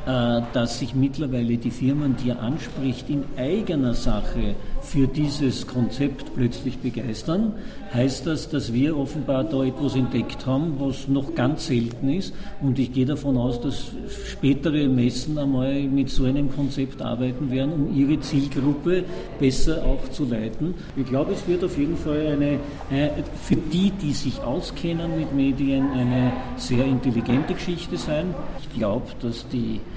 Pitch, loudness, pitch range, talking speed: 135 Hz, -24 LUFS, 125-145 Hz, 150 wpm